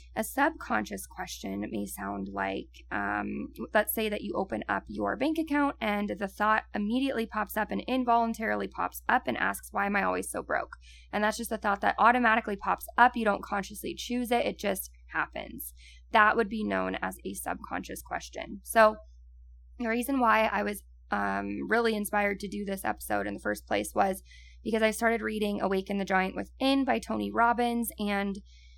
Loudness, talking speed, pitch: -29 LUFS, 185 wpm, 205 Hz